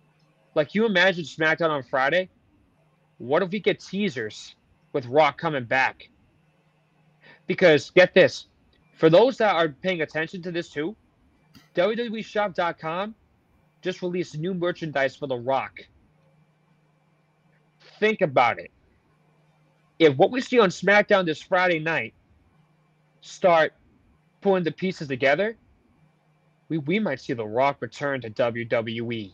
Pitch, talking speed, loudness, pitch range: 160 Hz, 125 wpm, -23 LUFS, 150-185 Hz